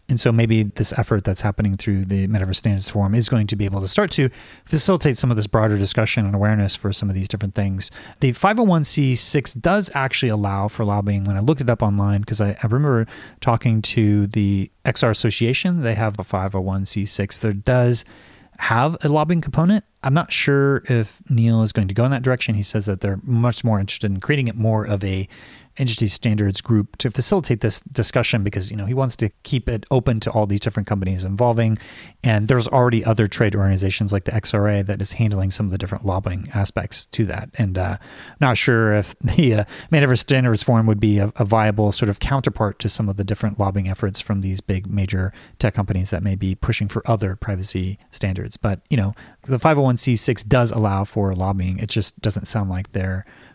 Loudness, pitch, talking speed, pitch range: -20 LUFS, 110 Hz, 210 wpm, 100-125 Hz